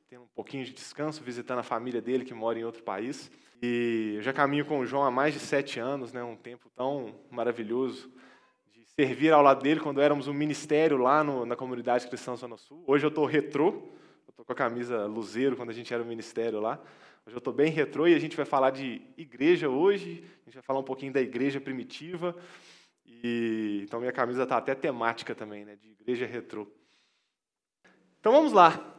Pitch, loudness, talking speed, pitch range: 130 Hz, -28 LUFS, 205 wpm, 120-145 Hz